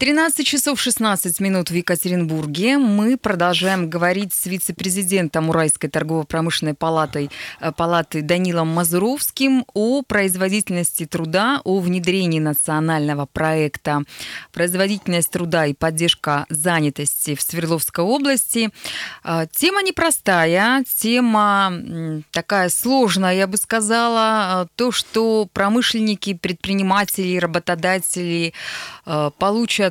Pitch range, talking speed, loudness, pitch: 165-210 Hz, 90 wpm, -19 LUFS, 185 Hz